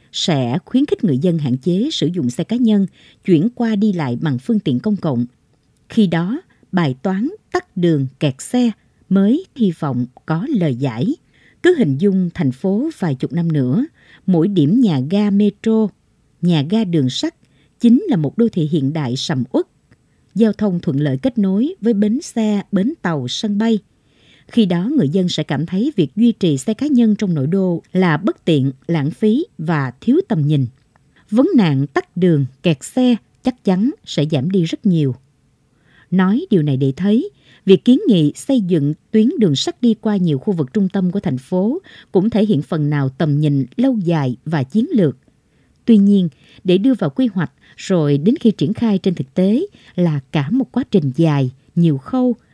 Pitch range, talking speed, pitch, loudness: 150-225 Hz, 195 wpm, 185 Hz, -17 LUFS